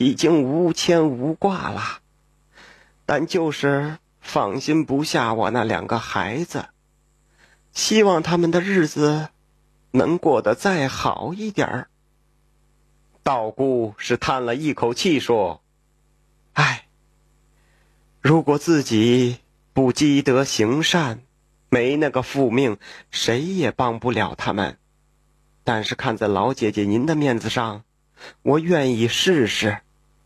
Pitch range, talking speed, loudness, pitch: 115-155 Hz, 165 characters per minute, -21 LUFS, 135 Hz